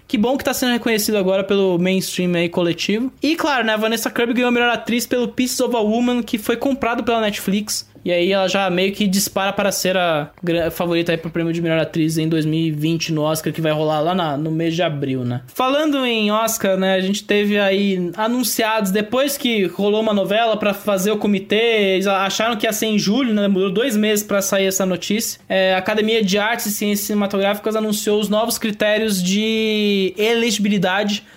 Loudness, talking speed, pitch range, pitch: -18 LUFS, 210 wpm, 185-225 Hz, 205 Hz